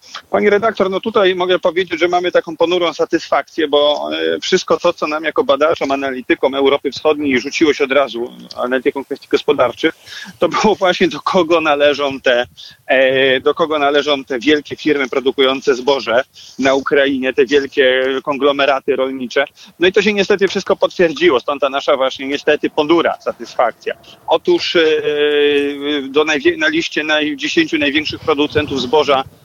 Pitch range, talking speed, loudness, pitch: 140-180 Hz, 150 wpm, -15 LUFS, 150 Hz